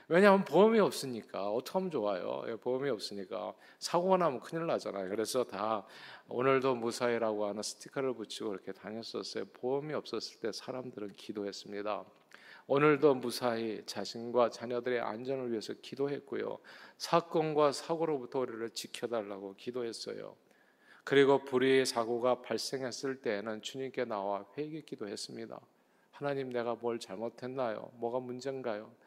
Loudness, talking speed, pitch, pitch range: -34 LUFS, 360 characters per minute, 125 Hz, 110-140 Hz